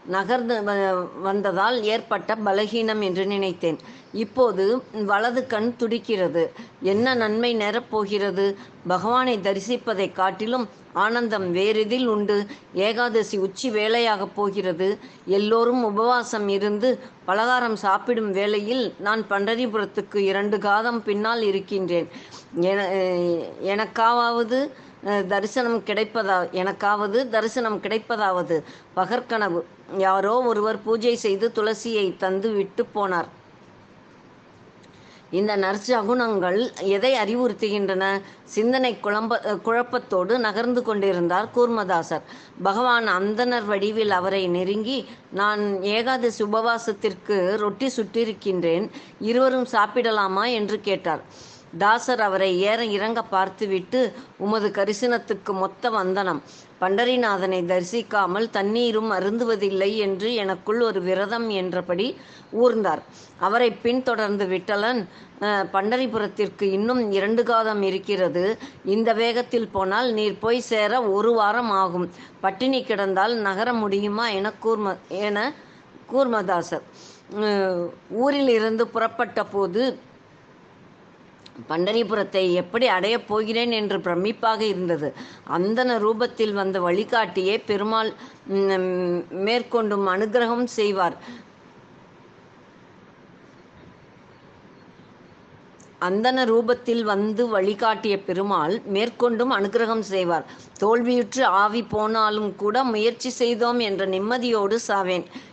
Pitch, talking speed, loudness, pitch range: 210 Hz, 85 wpm, -23 LUFS, 195-235 Hz